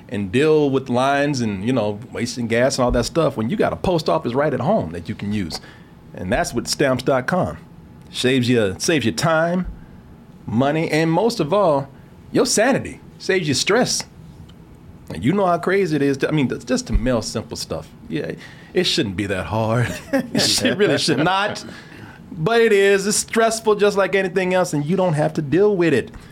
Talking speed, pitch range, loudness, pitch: 200 wpm, 120-185 Hz, -19 LUFS, 145 Hz